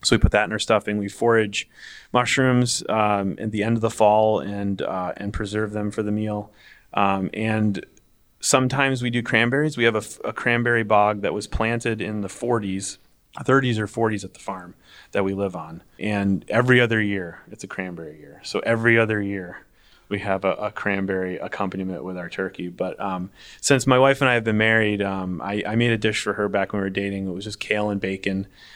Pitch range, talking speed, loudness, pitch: 100-115 Hz, 215 wpm, -22 LUFS, 105 Hz